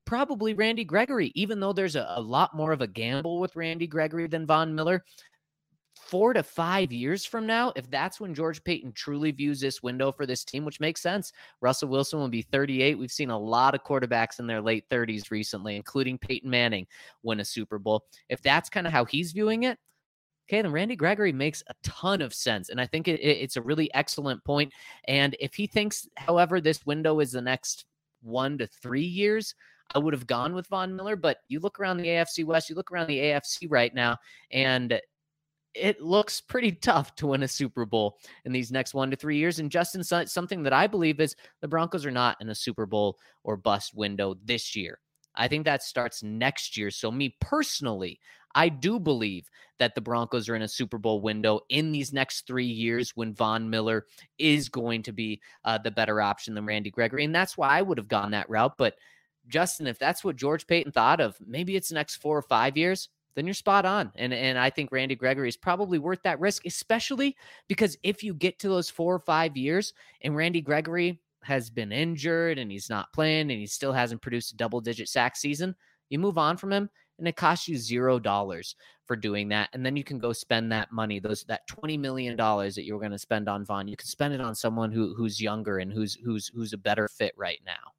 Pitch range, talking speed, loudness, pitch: 115-170 Hz, 220 wpm, -28 LUFS, 140 Hz